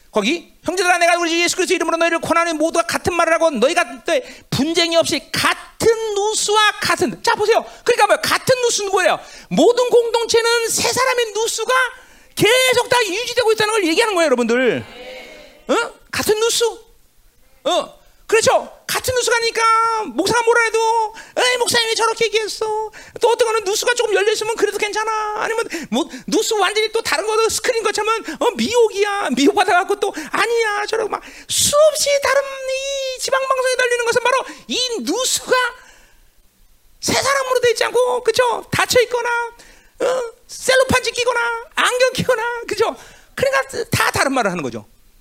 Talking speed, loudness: 355 characters per minute, -17 LUFS